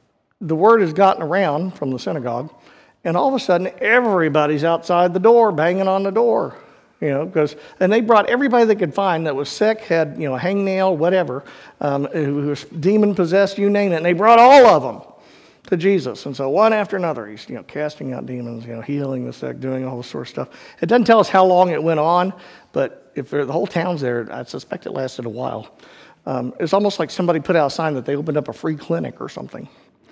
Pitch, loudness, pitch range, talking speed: 170 Hz, -18 LUFS, 145-195 Hz, 230 wpm